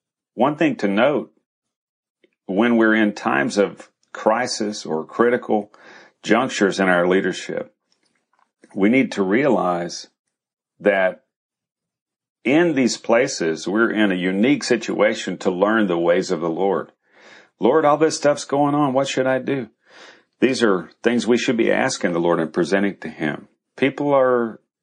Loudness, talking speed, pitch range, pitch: -19 LUFS, 145 wpm, 90-130 Hz, 105 Hz